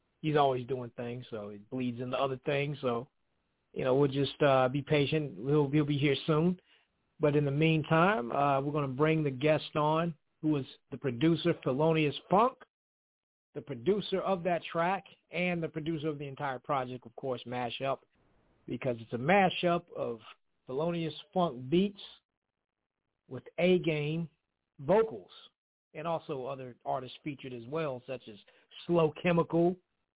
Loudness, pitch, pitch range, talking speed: -31 LUFS, 150 Hz, 130-165 Hz, 155 wpm